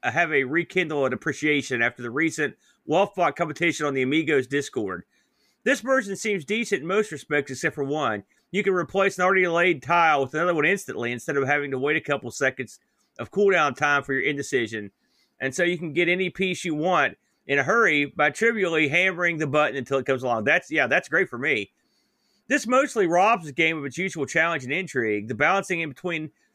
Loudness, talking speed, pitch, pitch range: -23 LUFS, 210 wpm, 160 Hz, 140-185 Hz